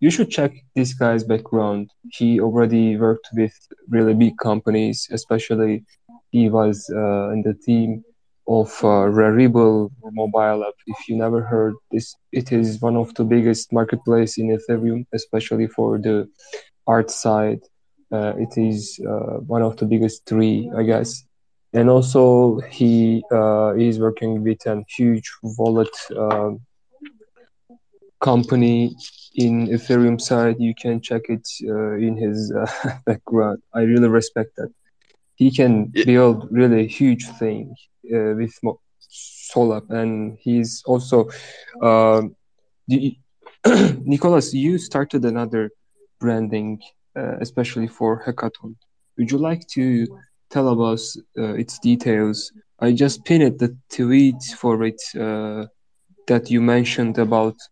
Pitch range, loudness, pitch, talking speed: 110-120 Hz, -19 LUFS, 115 Hz, 135 wpm